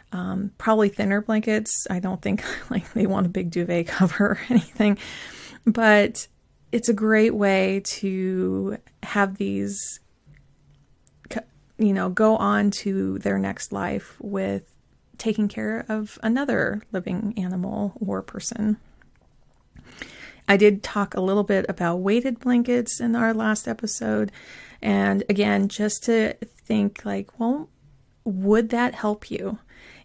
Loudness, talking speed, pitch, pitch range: -23 LUFS, 130 wpm, 205 Hz, 185-220 Hz